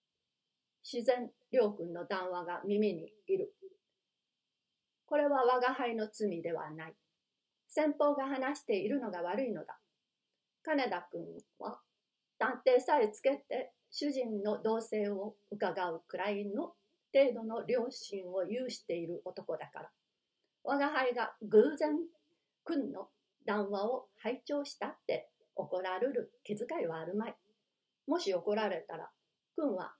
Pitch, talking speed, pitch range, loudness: 225 Hz, 240 characters per minute, 200-275 Hz, -35 LUFS